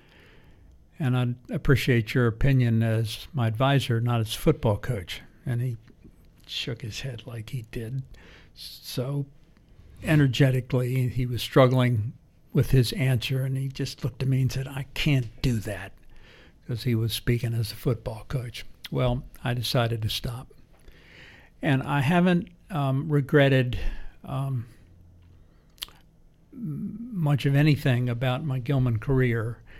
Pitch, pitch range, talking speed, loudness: 125 Hz, 115-135 Hz, 135 wpm, -26 LUFS